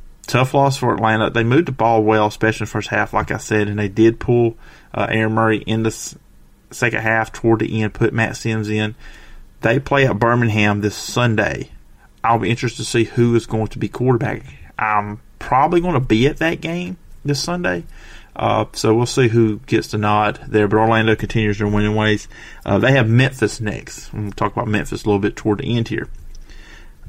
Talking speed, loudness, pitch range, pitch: 210 wpm, -18 LUFS, 105-120 Hz, 110 Hz